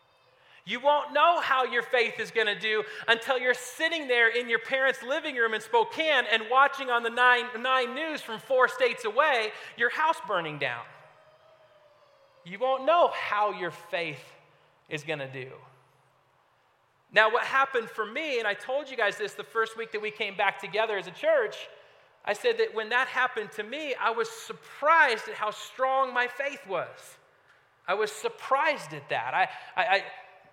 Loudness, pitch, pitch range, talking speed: -27 LUFS, 245 Hz, 215-290 Hz, 180 wpm